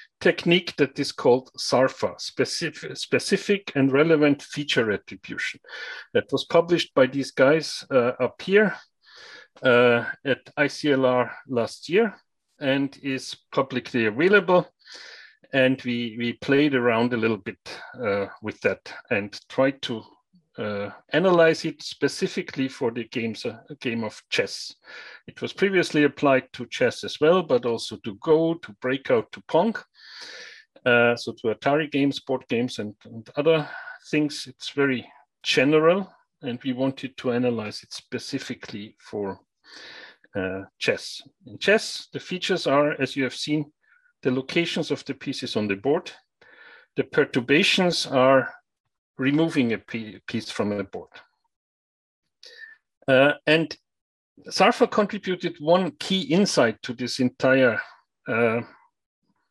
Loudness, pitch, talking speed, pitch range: -24 LUFS, 135 Hz, 130 wpm, 120-165 Hz